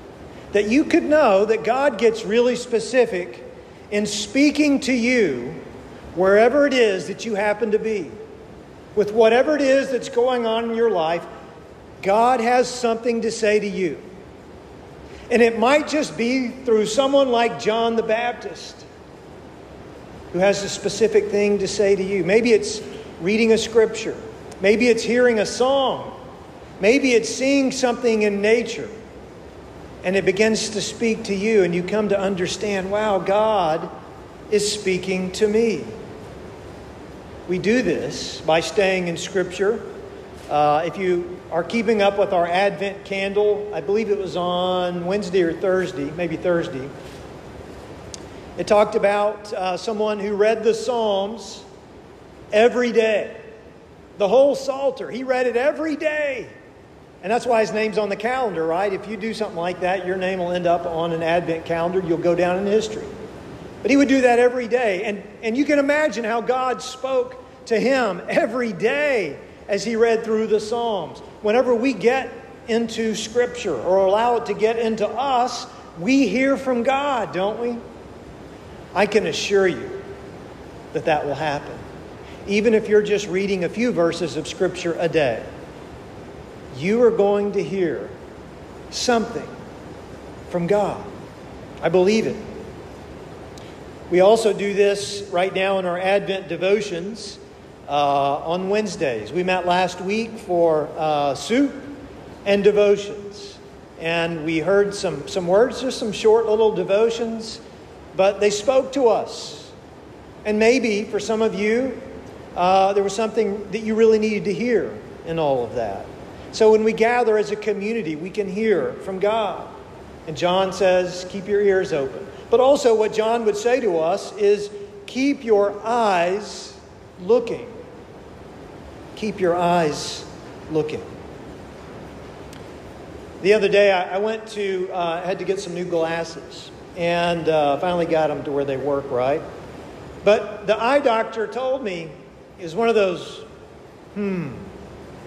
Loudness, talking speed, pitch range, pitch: -20 LUFS, 155 wpm, 185-230 Hz, 210 Hz